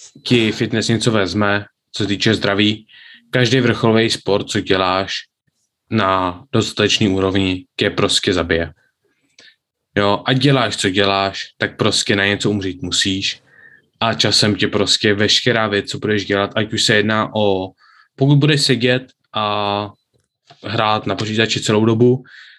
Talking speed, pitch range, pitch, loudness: 140 wpm, 100-115 Hz, 105 Hz, -16 LUFS